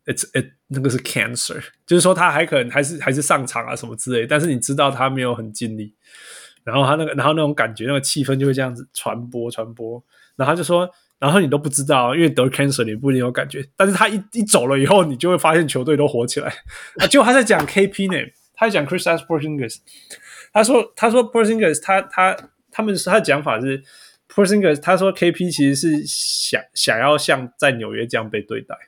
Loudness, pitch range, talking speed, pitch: -18 LUFS, 130-180 Hz, 405 characters per minute, 150 Hz